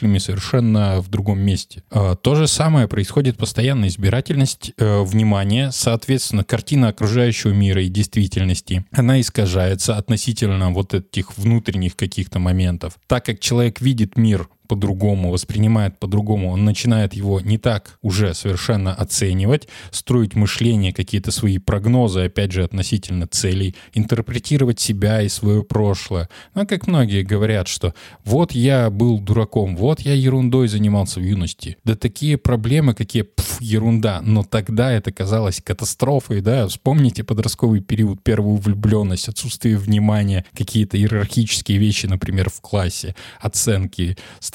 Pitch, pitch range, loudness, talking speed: 105 Hz, 95-115 Hz, -18 LUFS, 130 wpm